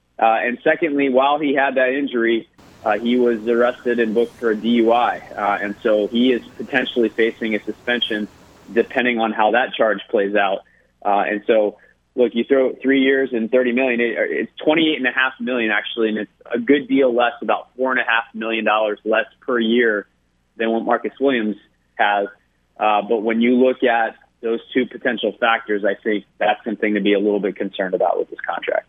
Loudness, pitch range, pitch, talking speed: -19 LUFS, 105-125 Hz, 115 Hz, 195 wpm